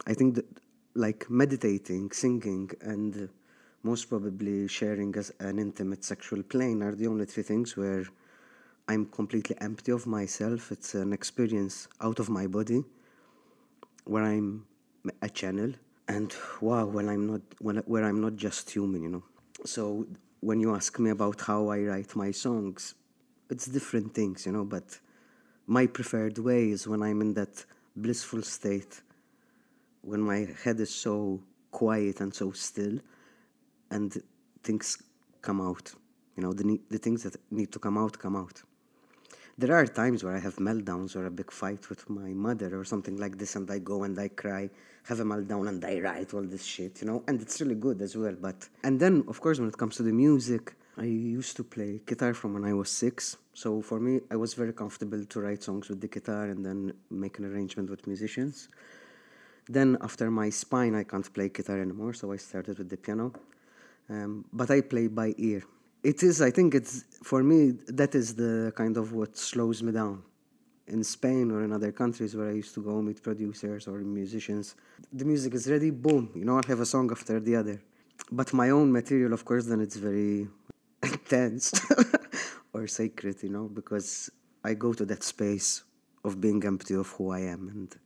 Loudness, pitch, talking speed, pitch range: -30 LUFS, 105 Hz, 190 wpm, 100-120 Hz